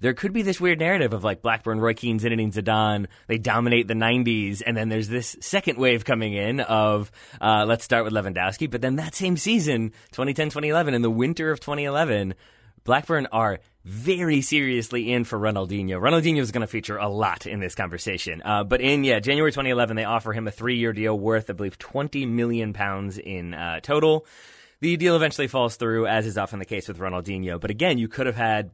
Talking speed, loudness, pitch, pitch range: 205 wpm, -24 LUFS, 115 Hz, 105-135 Hz